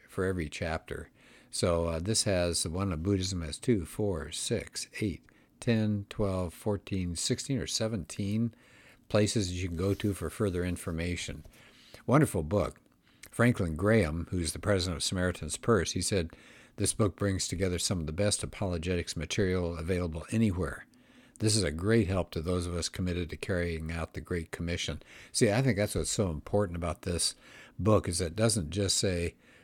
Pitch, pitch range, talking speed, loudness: 95 Hz, 85-105 Hz, 180 wpm, -31 LUFS